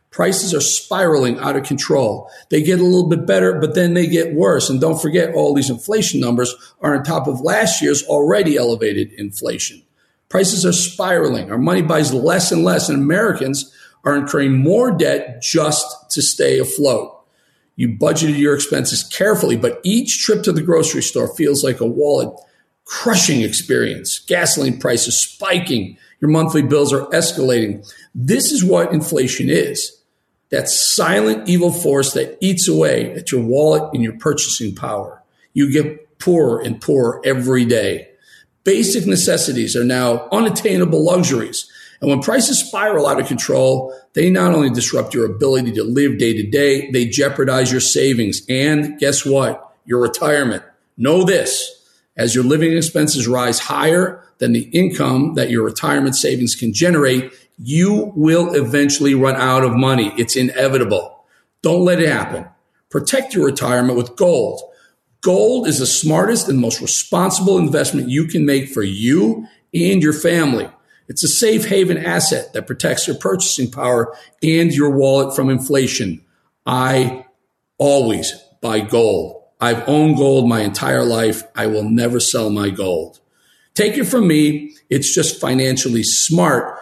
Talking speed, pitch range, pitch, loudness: 155 wpm, 125-165 Hz, 140 Hz, -16 LUFS